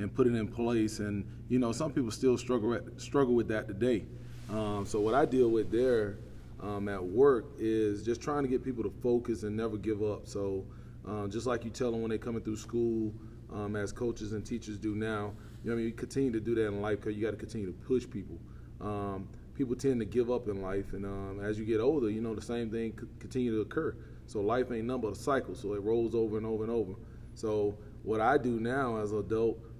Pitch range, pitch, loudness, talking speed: 105-120 Hz, 110 Hz, -33 LUFS, 245 wpm